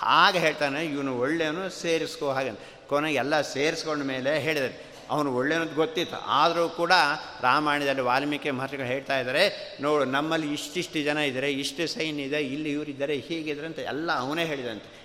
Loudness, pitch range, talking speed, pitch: -26 LUFS, 140-160 Hz, 150 wpm, 150 Hz